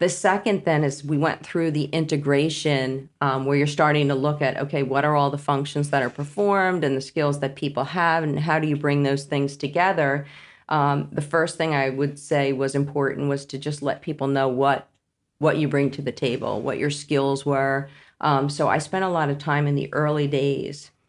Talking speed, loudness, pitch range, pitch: 220 wpm, -23 LUFS, 140-150 Hz, 145 Hz